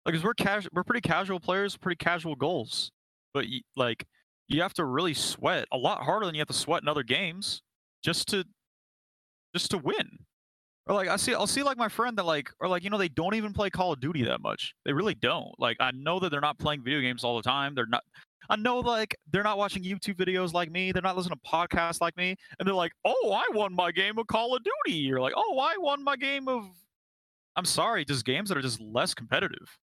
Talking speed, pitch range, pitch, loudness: 245 wpm, 155-205 Hz, 185 Hz, -29 LUFS